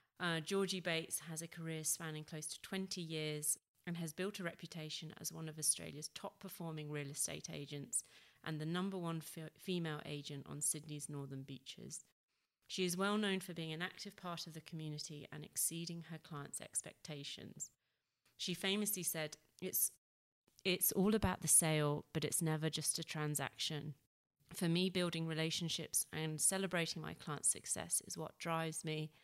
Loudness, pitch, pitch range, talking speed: -40 LUFS, 160 Hz, 150-175 Hz, 165 wpm